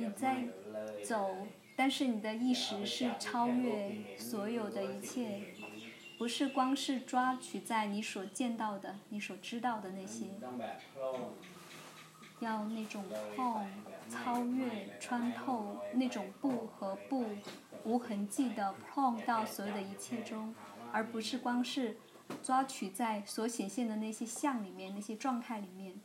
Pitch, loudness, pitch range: 220 Hz, -38 LUFS, 200-245 Hz